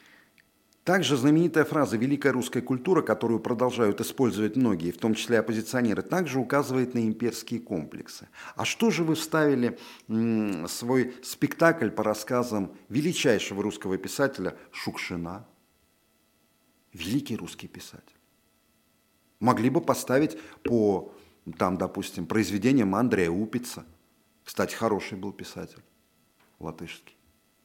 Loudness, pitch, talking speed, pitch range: -27 LUFS, 120 Hz, 110 wpm, 105-135 Hz